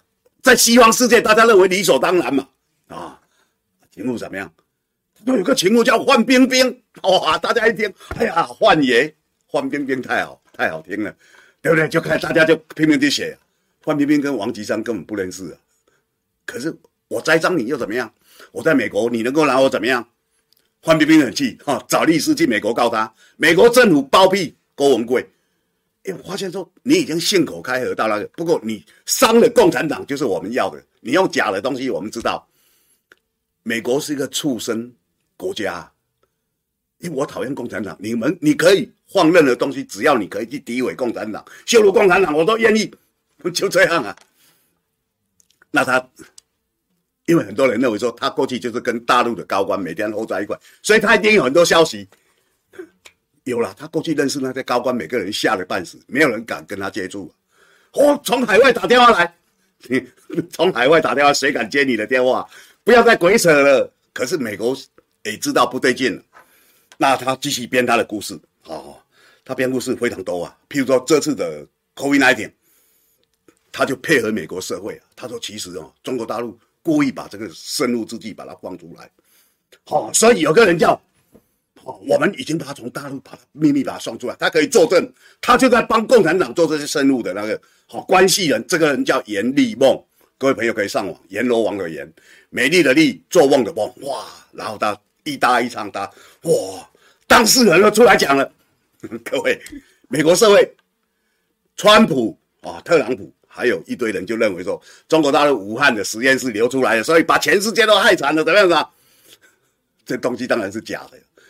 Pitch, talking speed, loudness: 185 Hz, 290 characters per minute, -16 LUFS